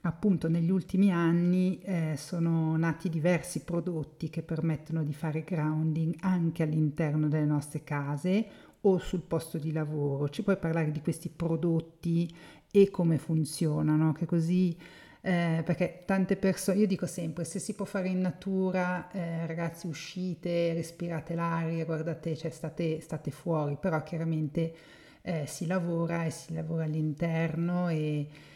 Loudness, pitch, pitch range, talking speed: -31 LUFS, 165 Hz, 160-180 Hz, 145 wpm